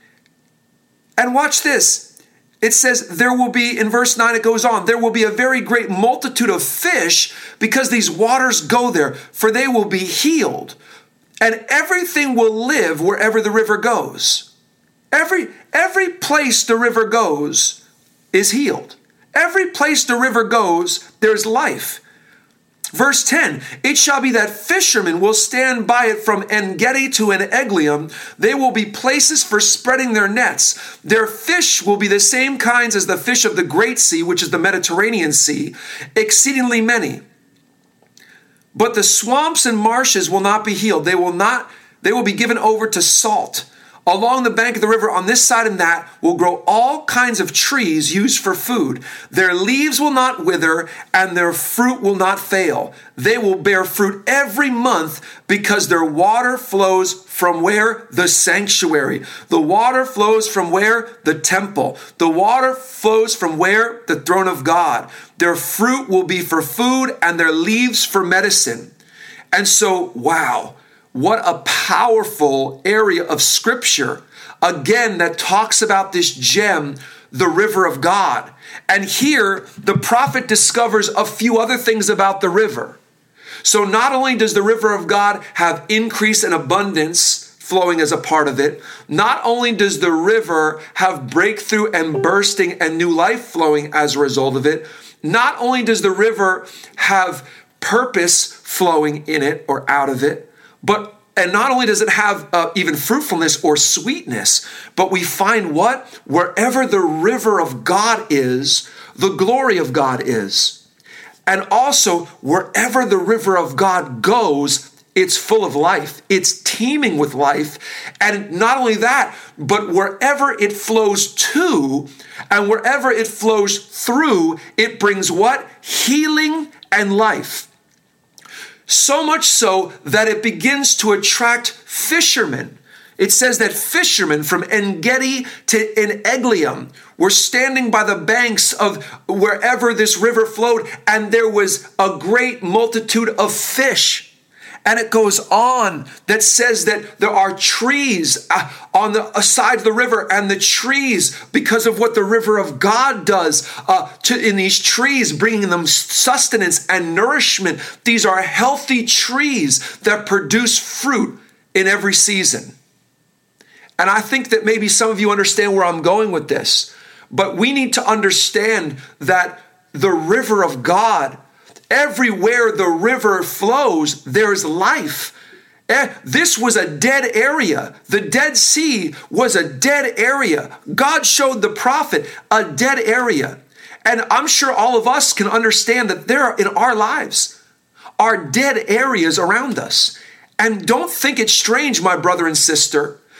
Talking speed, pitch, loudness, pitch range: 155 wpm, 215 Hz, -15 LUFS, 190-245 Hz